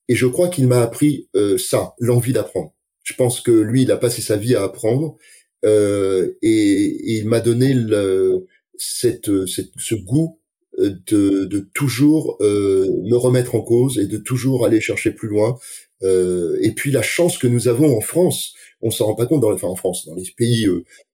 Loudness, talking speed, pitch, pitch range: -18 LUFS, 205 wpm, 125 Hz, 110-155 Hz